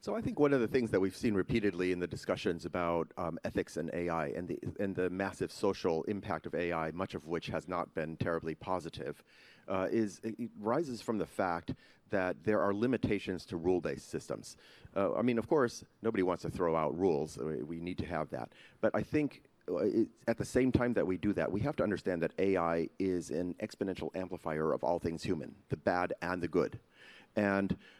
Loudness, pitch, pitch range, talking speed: -35 LUFS, 95 Hz, 85-115 Hz, 210 wpm